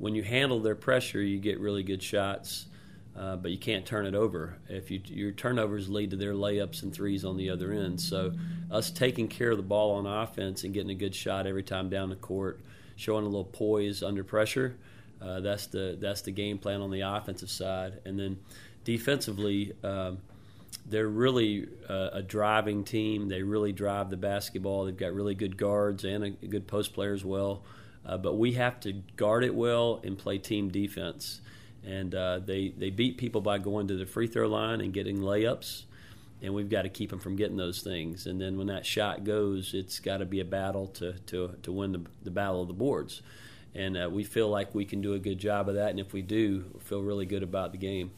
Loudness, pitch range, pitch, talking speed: -32 LUFS, 95-110 Hz, 100 Hz, 225 wpm